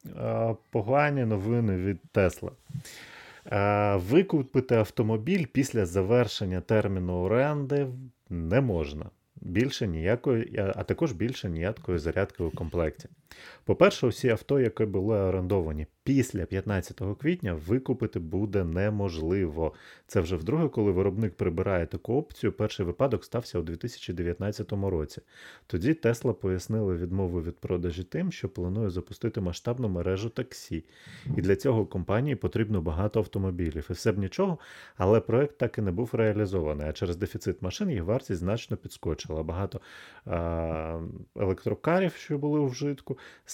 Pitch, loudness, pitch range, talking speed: 105 Hz, -29 LUFS, 90-120 Hz, 130 wpm